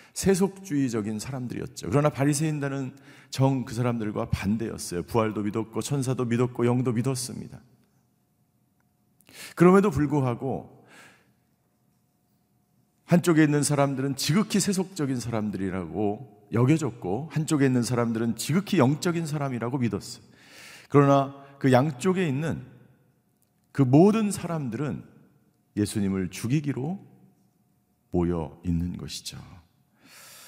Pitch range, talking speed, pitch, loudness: 115-150 Hz, 275 characters per minute, 135 Hz, -26 LUFS